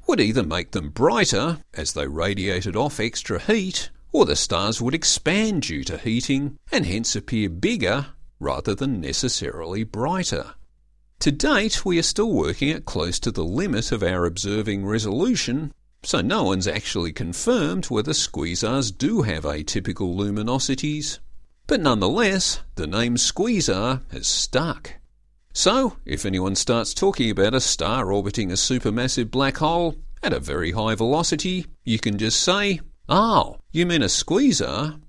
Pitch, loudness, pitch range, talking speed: 115 Hz, -22 LUFS, 100-150 Hz, 150 wpm